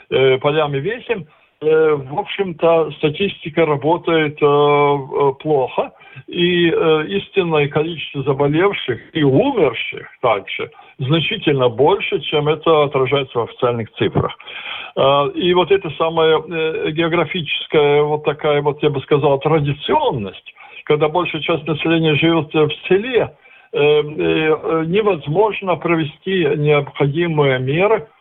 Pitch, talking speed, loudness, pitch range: 160 Hz, 100 wpm, -17 LUFS, 145-175 Hz